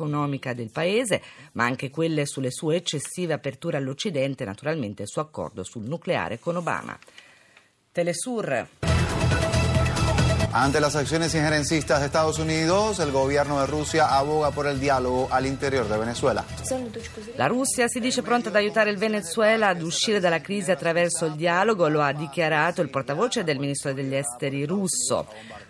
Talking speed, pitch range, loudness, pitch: 150 wpm, 135-175 Hz, -24 LUFS, 155 Hz